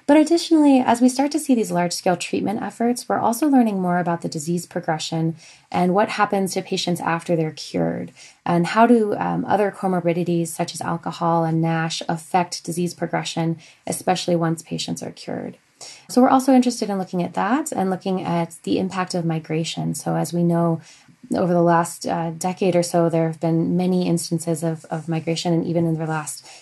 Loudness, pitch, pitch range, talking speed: -21 LUFS, 175 Hz, 165-195 Hz, 195 wpm